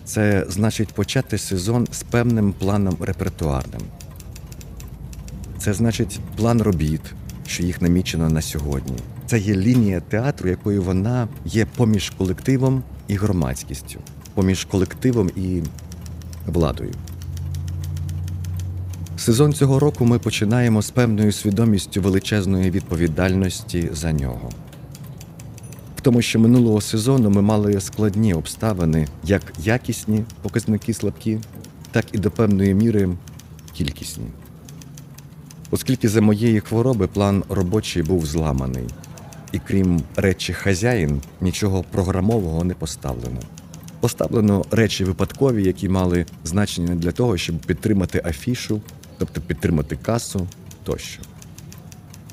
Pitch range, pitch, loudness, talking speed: 85-110 Hz, 100 Hz, -21 LUFS, 105 wpm